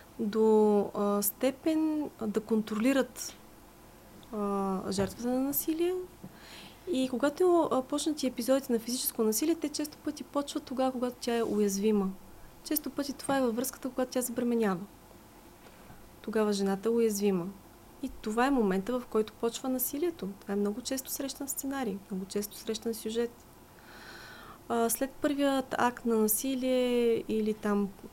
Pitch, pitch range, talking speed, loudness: 240 Hz, 215-270 Hz, 135 wpm, -31 LUFS